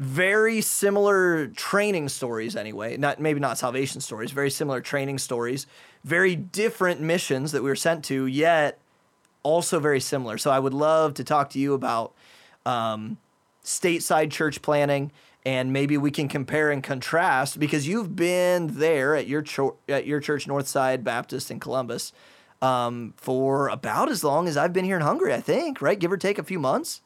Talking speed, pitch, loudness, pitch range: 175 wpm, 145 Hz, -24 LUFS, 135-170 Hz